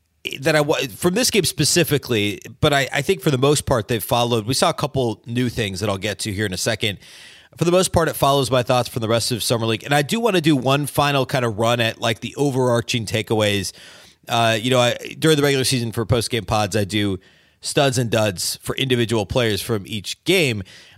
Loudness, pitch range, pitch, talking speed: -19 LUFS, 110-140 Hz, 120 Hz, 240 wpm